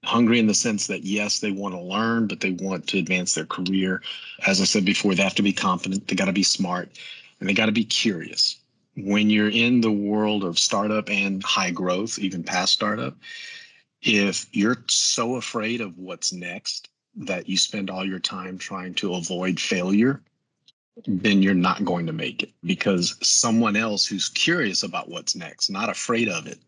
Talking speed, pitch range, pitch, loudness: 195 wpm, 95-110 Hz, 100 Hz, -22 LUFS